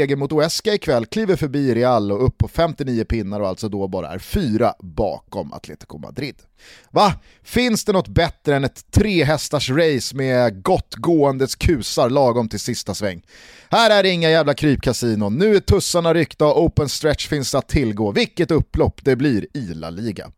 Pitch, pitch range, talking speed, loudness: 140 Hz, 115-165 Hz, 180 wpm, -19 LUFS